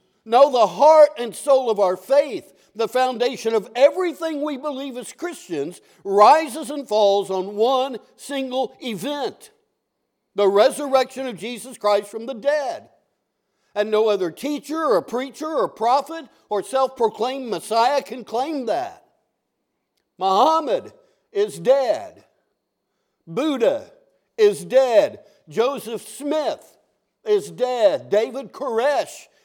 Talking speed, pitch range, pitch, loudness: 115 wpm, 220-300 Hz, 260 Hz, -20 LUFS